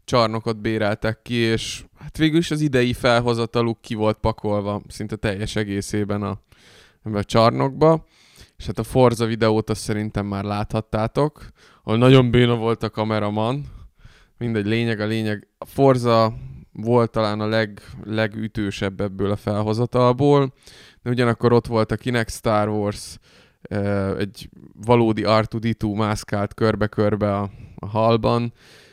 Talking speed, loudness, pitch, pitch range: 135 wpm, -21 LUFS, 110 Hz, 105-120 Hz